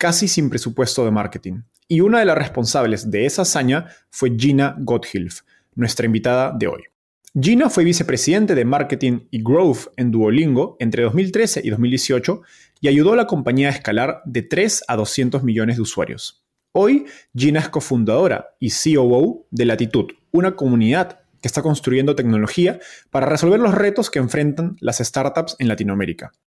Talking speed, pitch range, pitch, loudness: 160 wpm, 120-160 Hz, 135 Hz, -18 LUFS